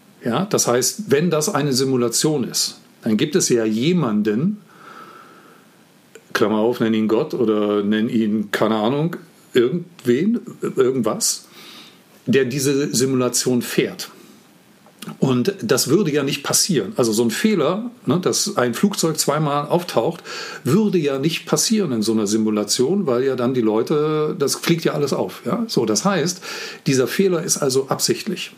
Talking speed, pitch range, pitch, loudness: 150 wpm, 120-200 Hz, 155 Hz, -19 LUFS